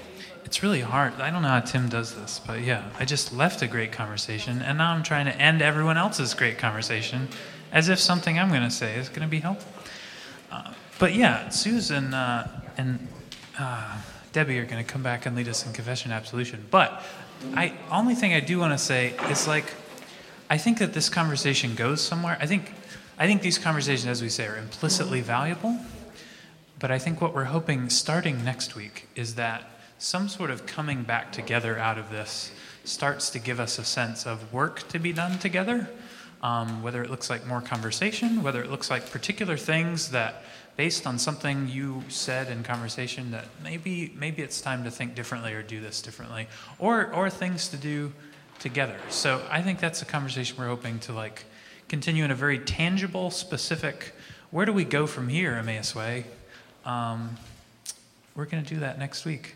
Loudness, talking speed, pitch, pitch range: -27 LUFS, 195 wpm, 135 Hz, 120-165 Hz